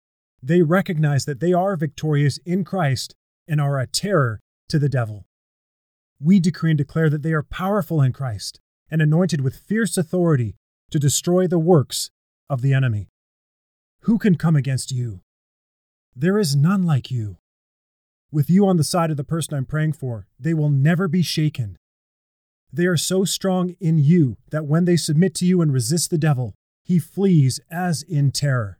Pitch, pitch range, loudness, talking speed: 150 Hz, 125-175 Hz, -20 LUFS, 175 wpm